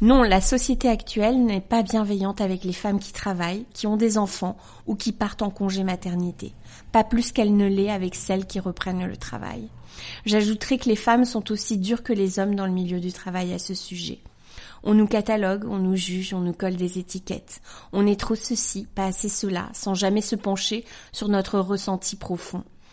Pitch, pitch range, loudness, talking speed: 200 Hz, 185-215 Hz, -24 LUFS, 200 wpm